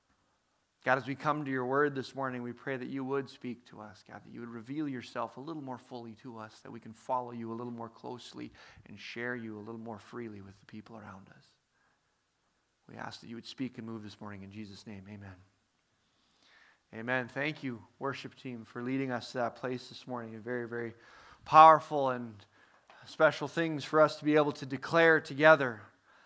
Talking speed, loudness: 210 wpm, -31 LUFS